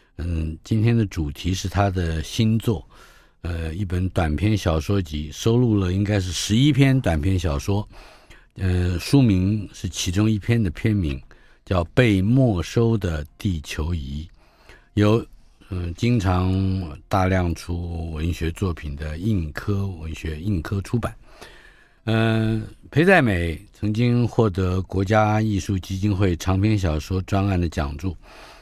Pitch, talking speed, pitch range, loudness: 95 Hz, 205 characters per minute, 85-110 Hz, -22 LUFS